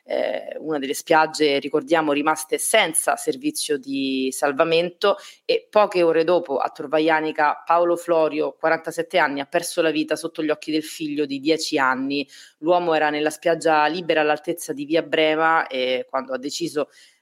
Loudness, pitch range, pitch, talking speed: -21 LUFS, 150-170 Hz, 155 Hz, 155 wpm